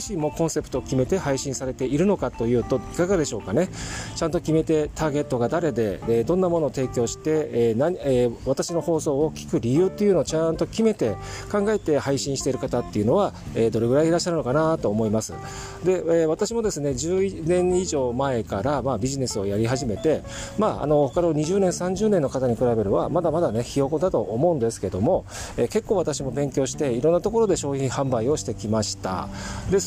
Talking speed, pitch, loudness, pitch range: 400 characters per minute, 140 Hz, -23 LUFS, 120-170 Hz